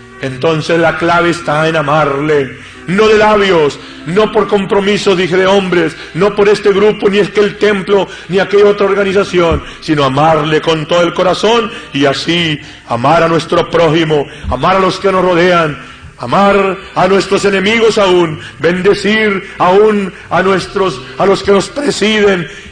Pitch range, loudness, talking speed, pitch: 160-200 Hz, -11 LUFS, 160 wpm, 185 Hz